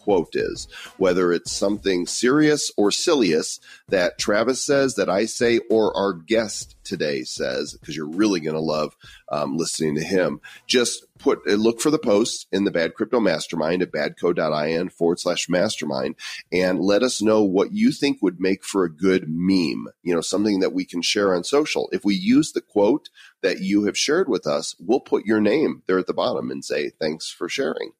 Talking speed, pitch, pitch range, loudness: 195 wpm, 105 Hz, 90-140 Hz, -22 LUFS